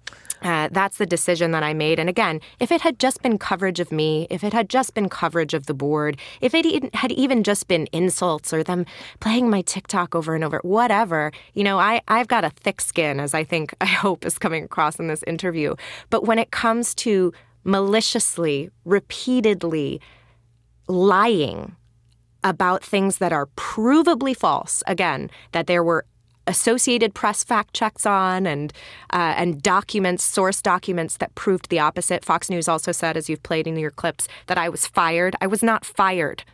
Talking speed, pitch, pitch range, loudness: 185 wpm, 180 Hz, 160-210 Hz, -21 LUFS